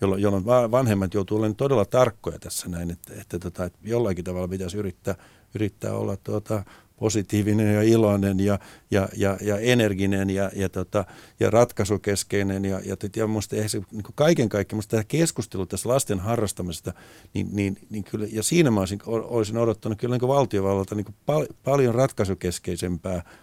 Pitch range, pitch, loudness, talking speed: 95-115 Hz, 105 Hz, -24 LUFS, 165 wpm